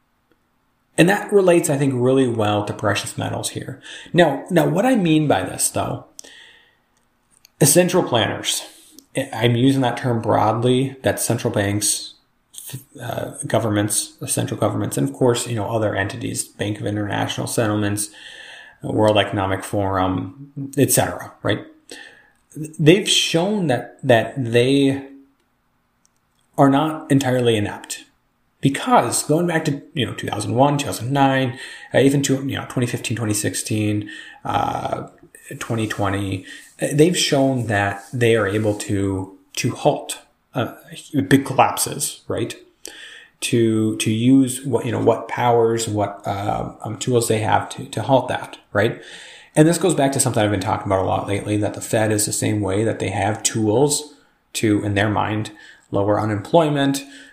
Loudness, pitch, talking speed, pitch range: -19 LUFS, 120 Hz, 145 wpm, 105-140 Hz